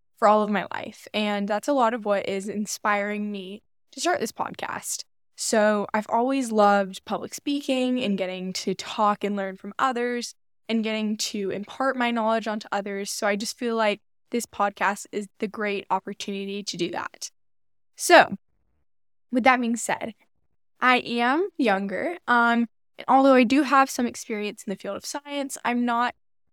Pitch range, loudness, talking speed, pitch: 200-245 Hz, -24 LUFS, 175 wpm, 215 Hz